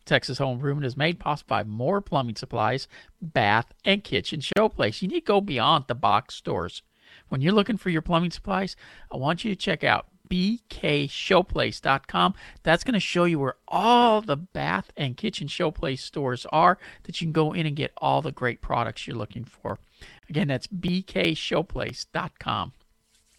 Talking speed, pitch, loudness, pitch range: 170 wpm, 160 Hz, -25 LUFS, 135-190 Hz